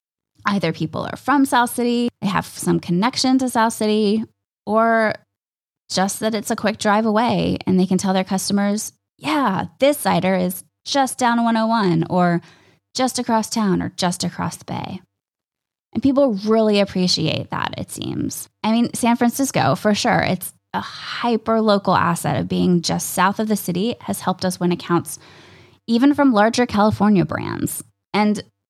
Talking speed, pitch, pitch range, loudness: 165 wpm, 205 Hz, 180-230 Hz, -19 LUFS